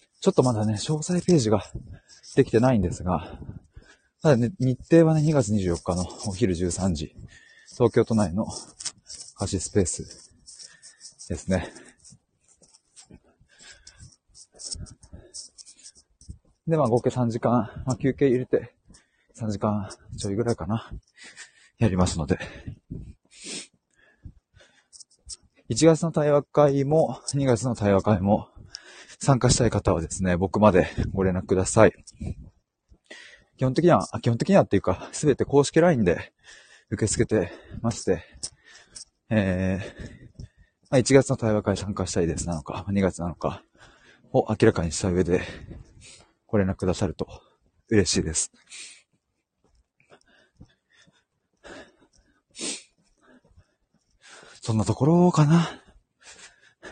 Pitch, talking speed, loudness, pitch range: 110 Hz, 205 characters per minute, -24 LUFS, 95-130 Hz